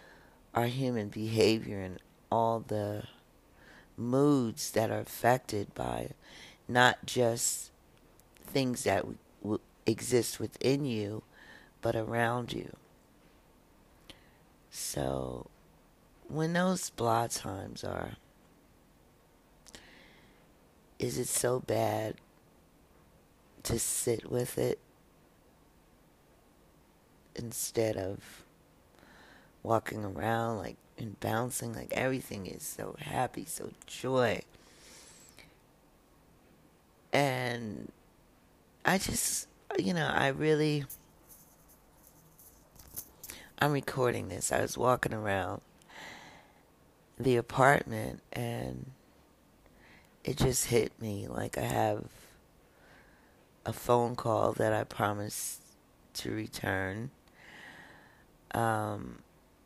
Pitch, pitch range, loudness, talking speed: 115 Hz, 105-125 Hz, -32 LUFS, 85 wpm